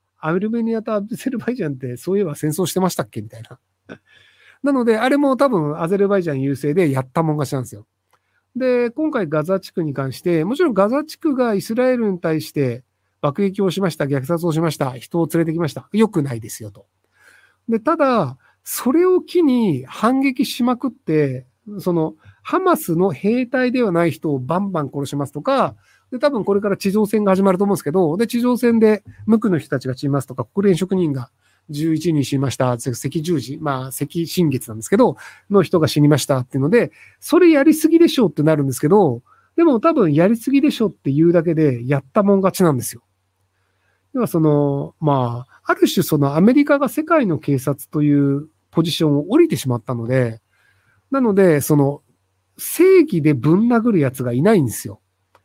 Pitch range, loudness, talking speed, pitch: 140-225 Hz, -18 LUFS, 380 characters per minute, 170 Hz